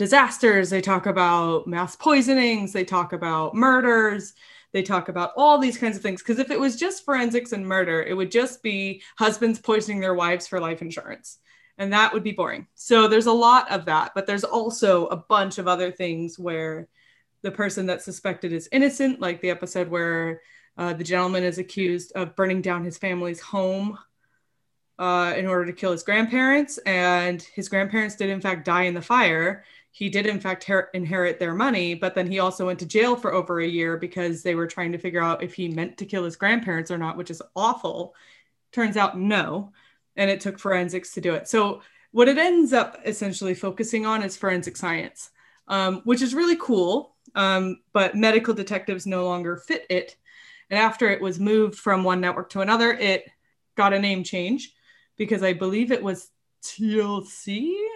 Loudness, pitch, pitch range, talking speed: -23 LUFS, 195 Hz, 180-220 Hz, 195 wpm